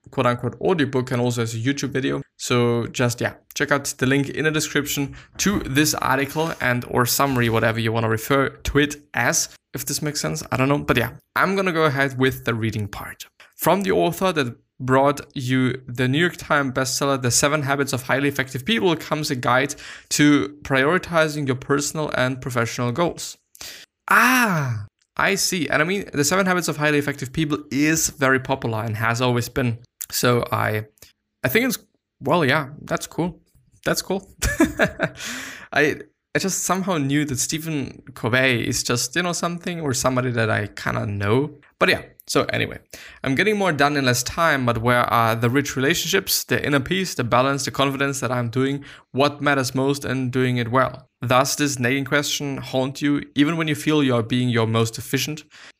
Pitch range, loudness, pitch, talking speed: 125-150 Hz, -21 LUFS, 135 Hz, 190 wpm